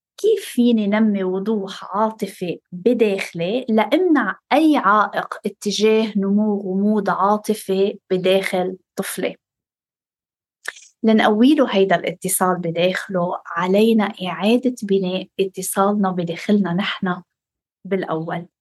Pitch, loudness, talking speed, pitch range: 195 Hz, -19 LUFS, 85 wpm, 185-220 Hz